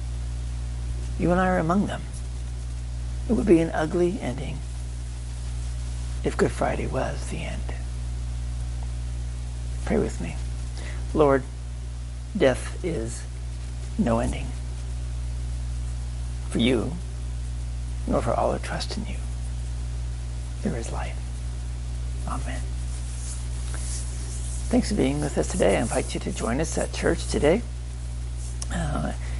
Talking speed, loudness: 110 wpm, -28 LUFS